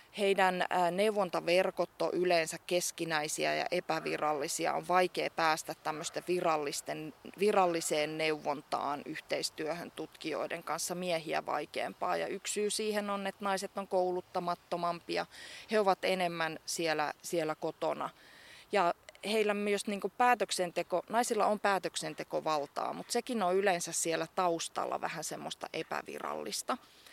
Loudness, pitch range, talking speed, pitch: -33 LUFS, 165-195 Hz, 115 wpm, 180 Hz